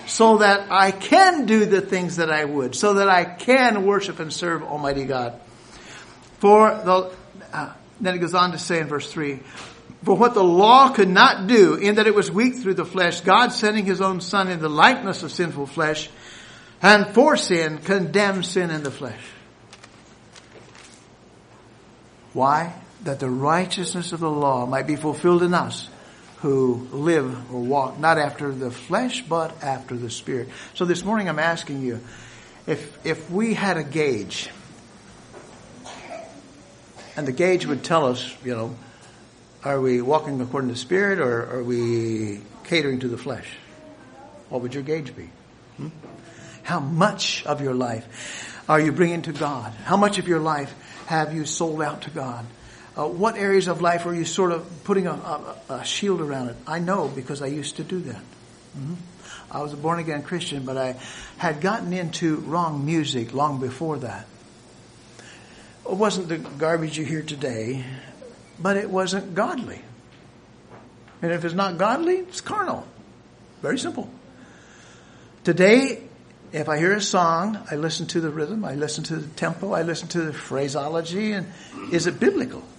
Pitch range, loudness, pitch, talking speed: 135-185 Hz, -21 LUFS, 160 Hz, 170 wpm